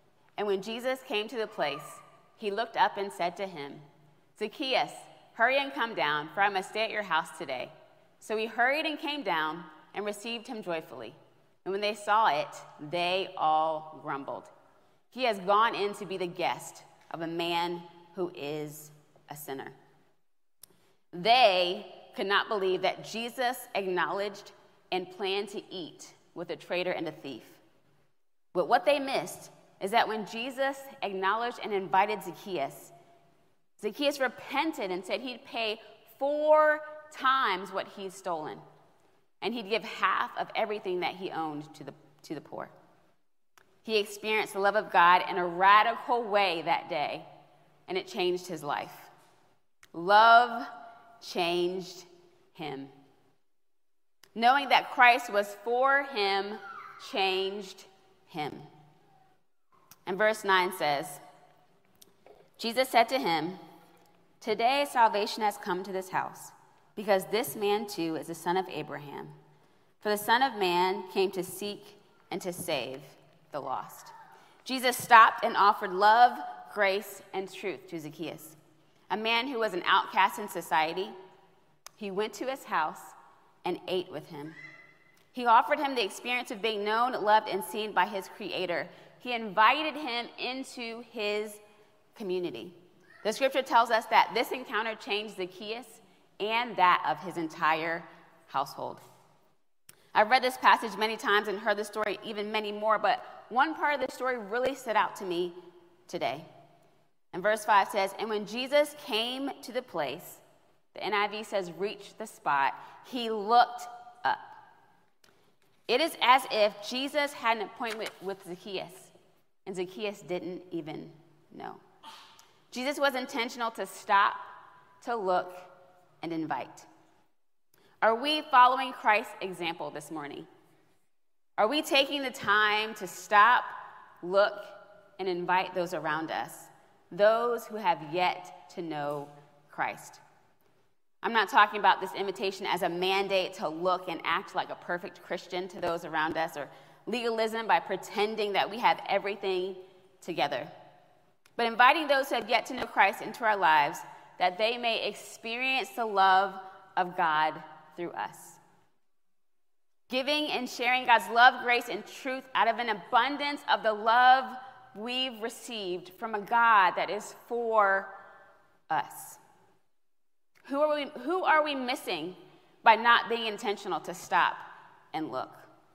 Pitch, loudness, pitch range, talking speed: 205 Hz, -29 LUFS, 180-235 Hz, 145 wpm